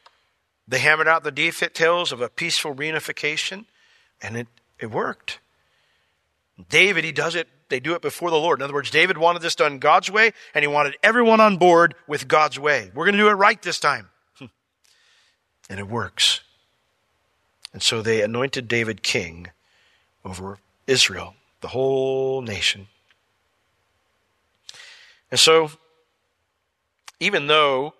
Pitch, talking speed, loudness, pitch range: 135 Hz, 145 wpm, -19 LUFS, 105-160 Hz